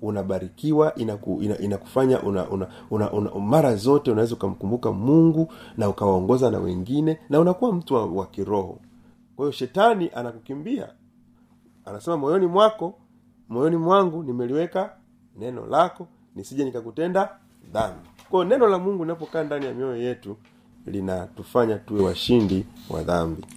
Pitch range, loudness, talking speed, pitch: 100-160 Hz, -23 LUFS, 130 wpm, 125 Hz